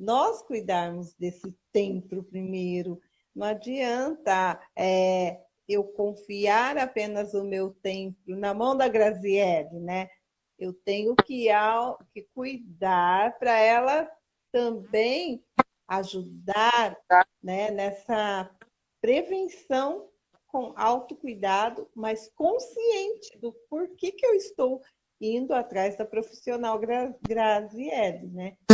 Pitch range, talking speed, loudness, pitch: 195-250 Hz, 100 wpm, -27 LUFS, 220 Hz